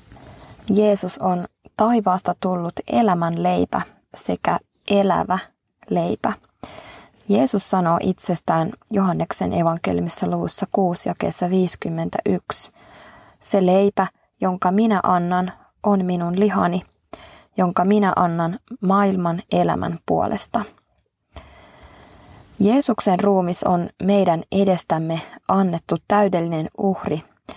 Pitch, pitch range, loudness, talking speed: 185 Hz, 175-200 Hz, -20 LUFS, 85 wpm